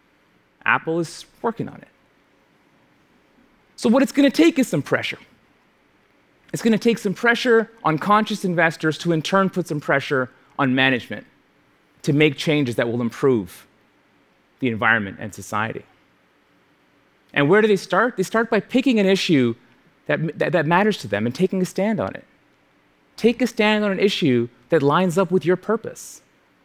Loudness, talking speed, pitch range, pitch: -20 LUFS, 170 wpm, 140-210 Hz, 175 Hz